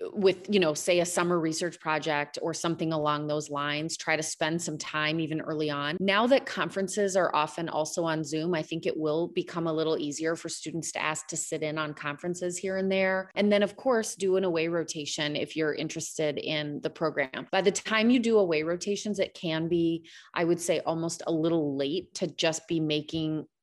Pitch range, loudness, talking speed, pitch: 155-185 Hz, -29 LUFS, 215 wpm, 165 Hz